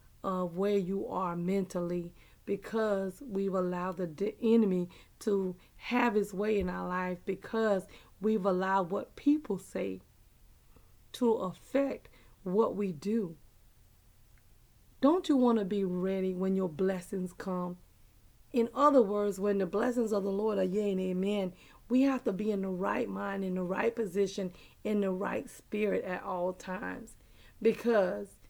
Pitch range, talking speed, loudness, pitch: 180-210 Hz, 150 wpm, -32 LUFS, 195 Hz